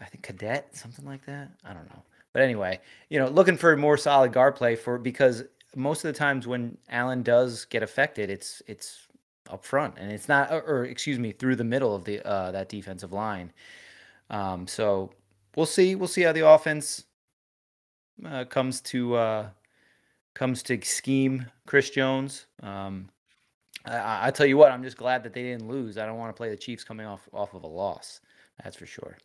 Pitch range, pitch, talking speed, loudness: 110-140 Hz, 125 Hz, 200 wpm, -25 LUFS